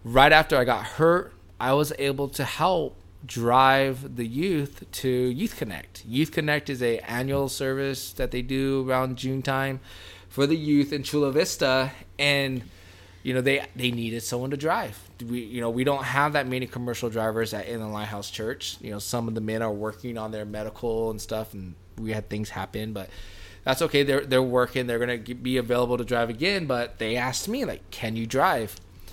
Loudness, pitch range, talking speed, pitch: -26 LUFS, 110-135 Hz, 200 wpm, 125 Hz